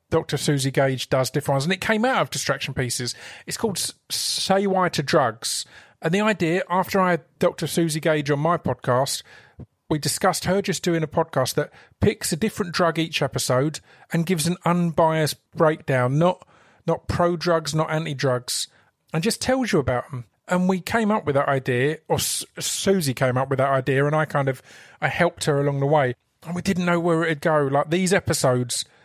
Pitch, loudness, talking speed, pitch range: 160 Hz, -22 LUFS, 200 wpm, 140-175 Hz